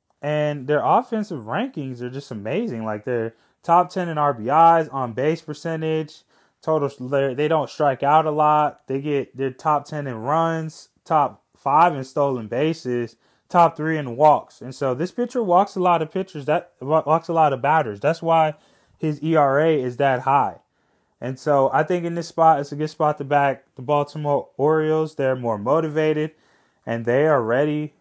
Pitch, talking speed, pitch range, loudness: 150 Hz, 180 wpm, 135-160 Hz, -21 LUFS